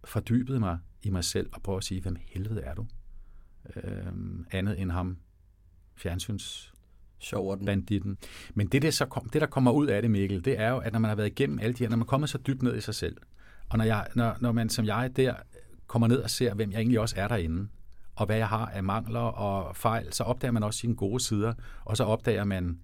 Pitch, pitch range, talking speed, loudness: 110 Hz, 95-115 Hz, 235 wpm, -29 LUFS